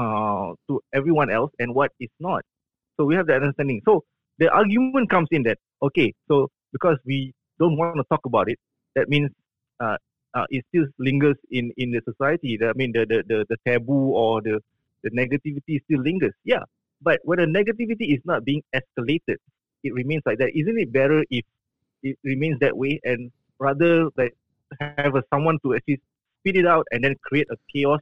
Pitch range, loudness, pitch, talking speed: 125-155 Hz, -23 LUFS, 140 Hz, 195 wpm